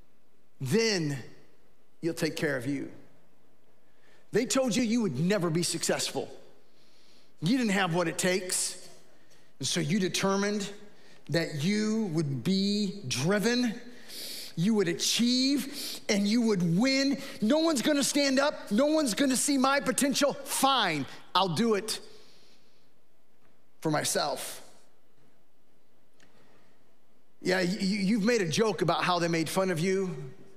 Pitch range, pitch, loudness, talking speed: 175-245 Hz, 205 Hz, -28 LUFS, 130 wpm